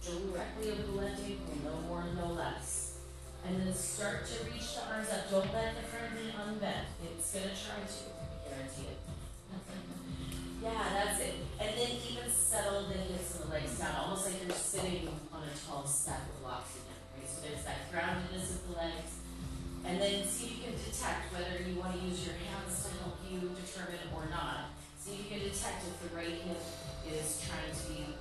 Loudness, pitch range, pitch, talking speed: -38 LUFS, 120-190 Hz, 170 Hz, 205 wpm